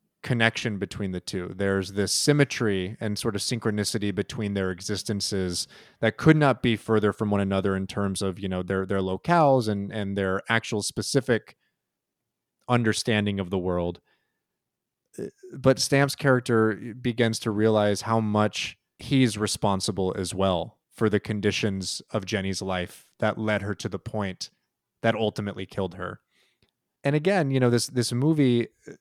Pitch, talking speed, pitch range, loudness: 105 Hz, 155 wpm, 95-120 Hz, -25 LUFS